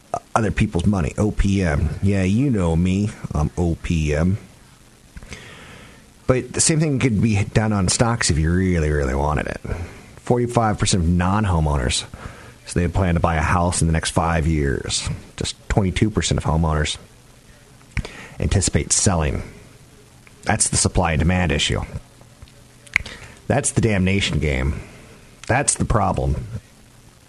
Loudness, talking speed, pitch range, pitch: -20 LUFS, 130 wpm, 80-110 Hz, 95 Hz